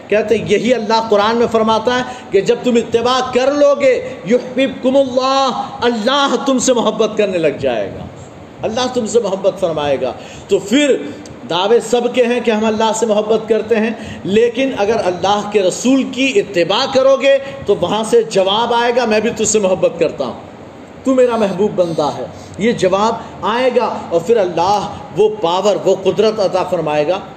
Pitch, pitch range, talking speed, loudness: 225 Hz, 200-250 Hz, 185 wpm, -14 LUFS